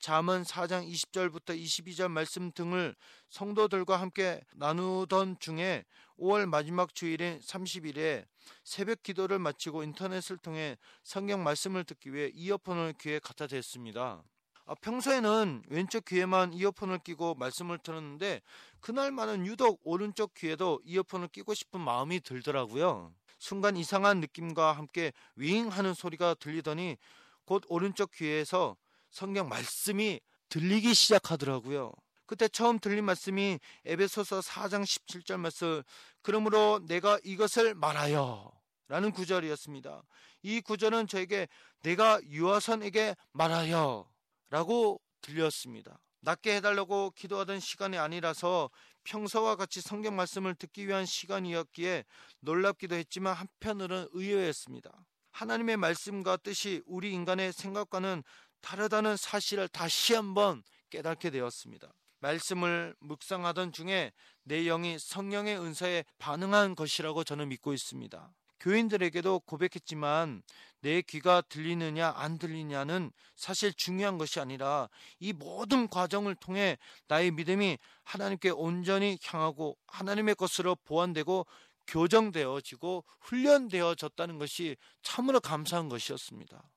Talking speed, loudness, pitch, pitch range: 305 characters per minute, -32 LUFS, 180 Hz, 160-200 Hz